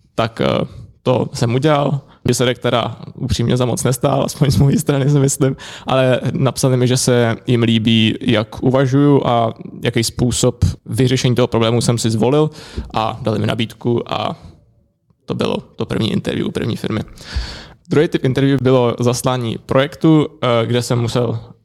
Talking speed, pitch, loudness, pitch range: 155 wpm, 125 Hz, -16 LUFS, 115-135 Hz